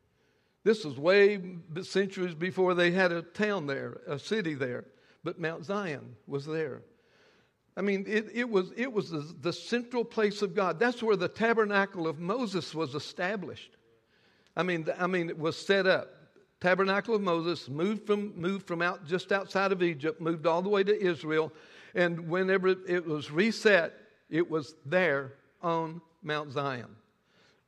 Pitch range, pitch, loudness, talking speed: 160-200 Hz, 180 Hz, -30 LUFS, 165 wpm